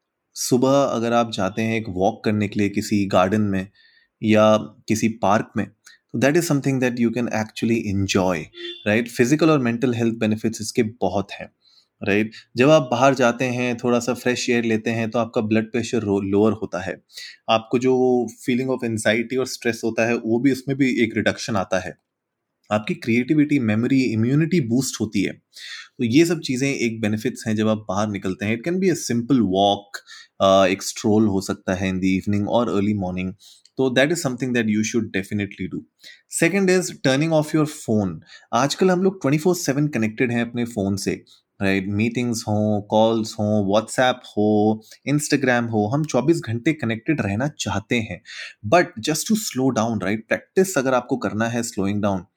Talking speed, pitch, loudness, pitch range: 185 wpm, 115 Hz, -21 LUFS, 105-130 Hz